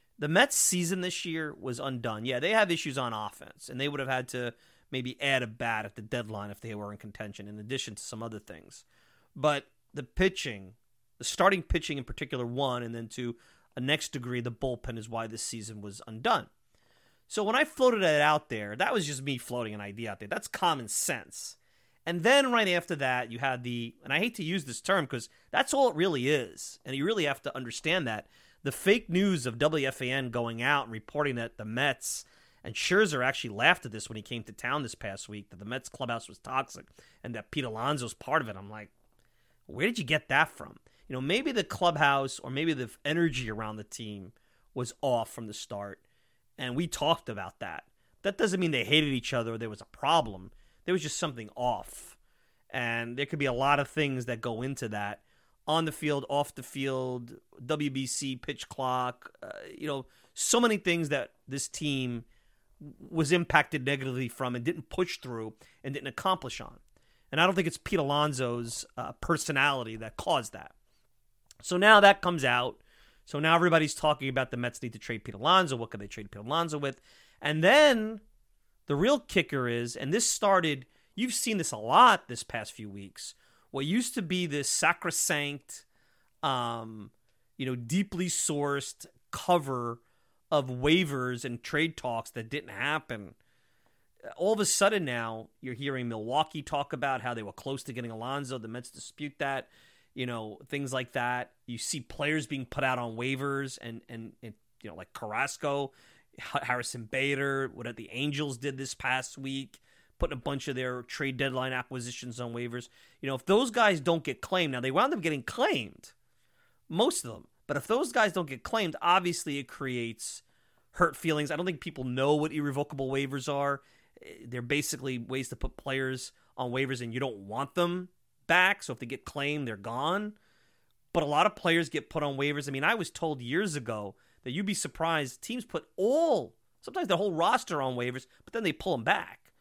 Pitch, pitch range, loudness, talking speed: 135 Hz, 120-155 Hz, -30 LUFS, 200 wpm